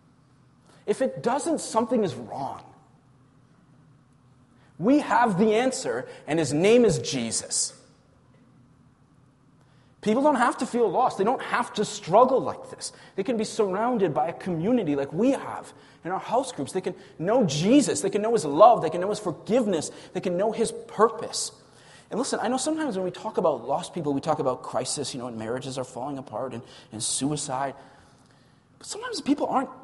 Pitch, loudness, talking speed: 185 Hz, -25 LUFS, 180 wpm